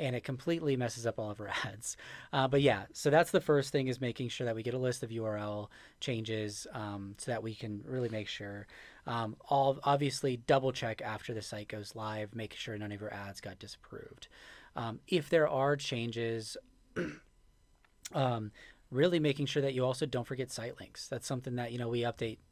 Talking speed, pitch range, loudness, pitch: 205 wpm, 110-135 Hz, -35 LUFS, 120 Hz